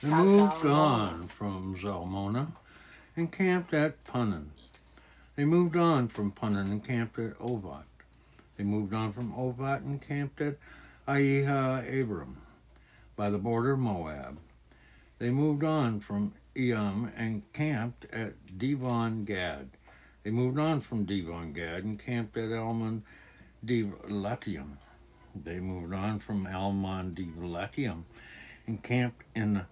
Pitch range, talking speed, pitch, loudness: 95-130 Hz, 125 wpm, 110 Hz, -31 LUFS